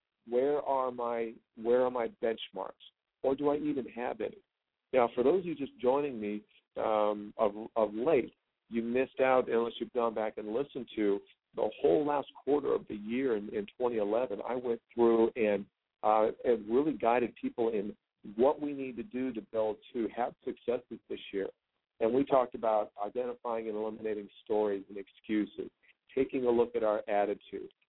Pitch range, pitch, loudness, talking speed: 110-130 Hz, 115 Hz, -32 LUFS, 180 wpm